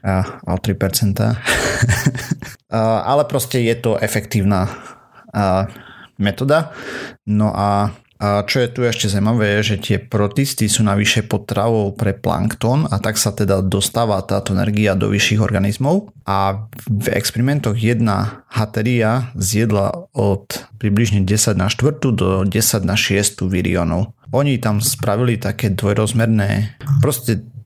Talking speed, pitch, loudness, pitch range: 125 wpm, 110 Hz, -17 LUFS, 100-120 Hz